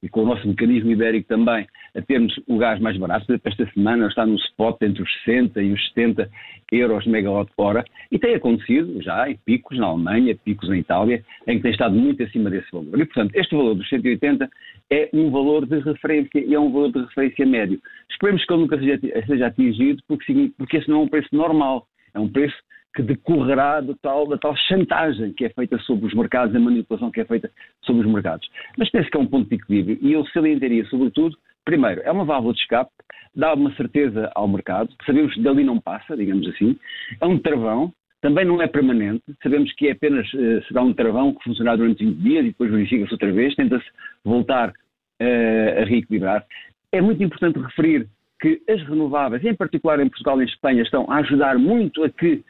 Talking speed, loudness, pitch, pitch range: 210 wpm, -20 LUFS, 140 Hz, 115-180 Hz